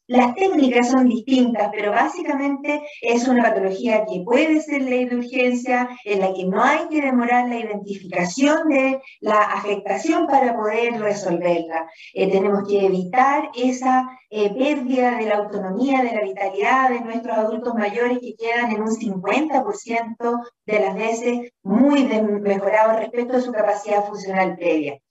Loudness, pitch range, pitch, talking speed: -20 LUFS, 205-255 Hz, 235 Hz, 150 wpm